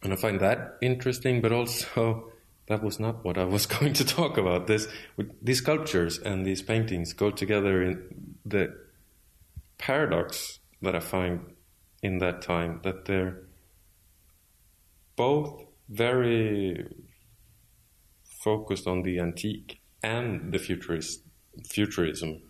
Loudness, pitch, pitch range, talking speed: -28 LUFS, 95 Hz, 90-110 Hz, 125 wpm